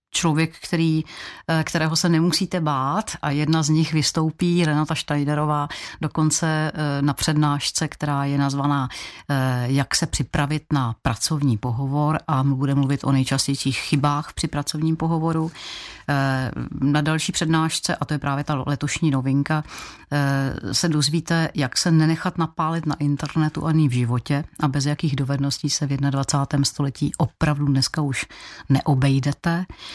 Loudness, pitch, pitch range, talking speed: -22 LUFS, 150 Hz, 140-160 Hz, 135 wpm